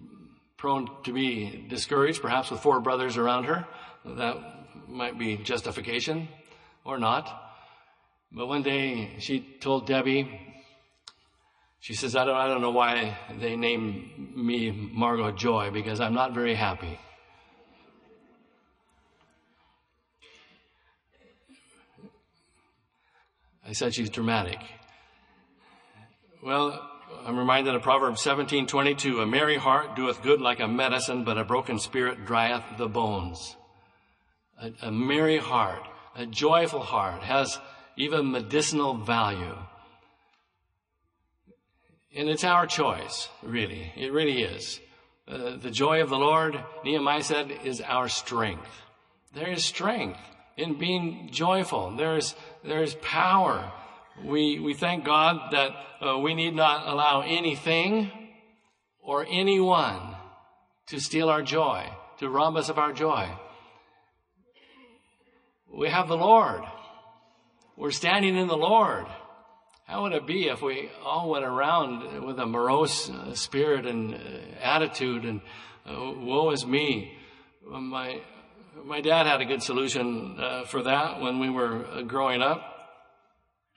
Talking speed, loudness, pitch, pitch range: 125 wpm, -27 LUFS, 135 Hz, 115-155 Hz